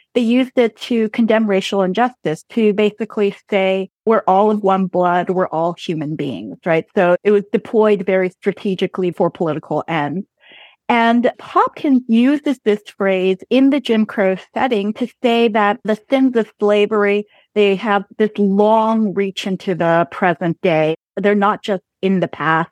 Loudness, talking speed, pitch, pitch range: -17 LUFS, 160 wpm, 205 Hz, 185-220 Hz